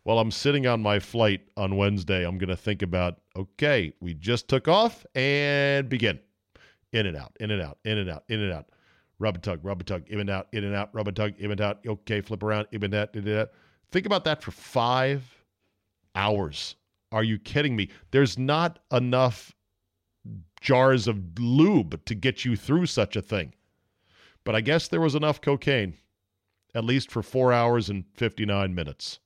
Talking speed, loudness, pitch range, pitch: 200 wpm, -26 LUFS, 95-130 Hz, 105 Hz